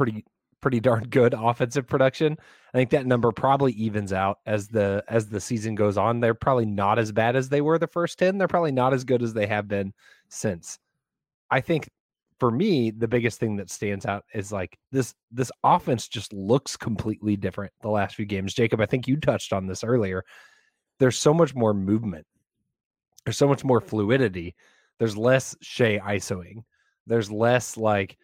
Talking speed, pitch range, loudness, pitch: 190 wpm, 105-130 Hz, -24 LUFS, 115 Hz